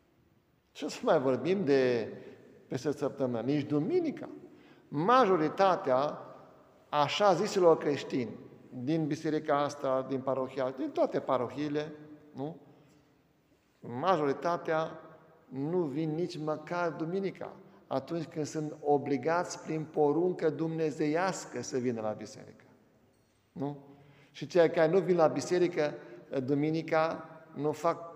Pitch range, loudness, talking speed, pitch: 140-165 Hz, -31 LUFS, 105 wpm, 150 Hz